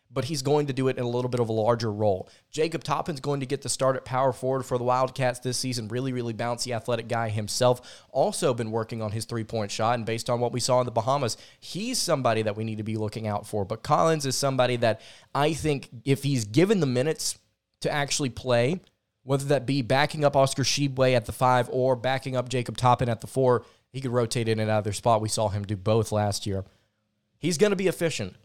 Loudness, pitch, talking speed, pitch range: -26 LUFS, 125 Hz, 245 wpm, 110-135 Hz